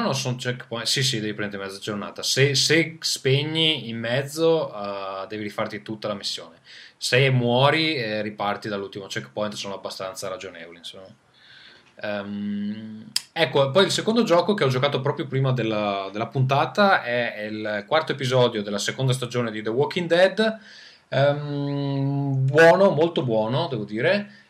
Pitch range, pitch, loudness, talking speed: 105-155 Hz, 130 Hz, -23 LUFS, 150 wpm